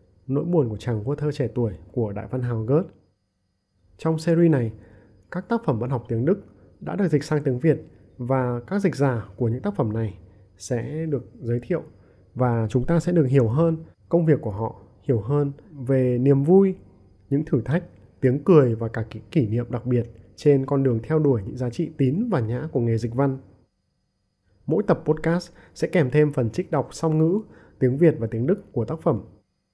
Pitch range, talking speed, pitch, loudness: 110-155 Hz, 210 wpm, 130 Hz, -23 LUFS